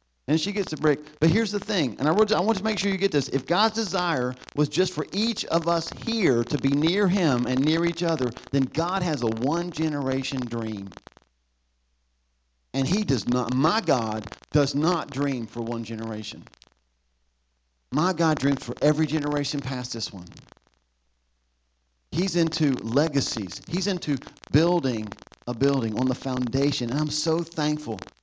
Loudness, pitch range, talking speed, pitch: -25 LUFS, 110-160 Hz, 170 wpm, 140 Hz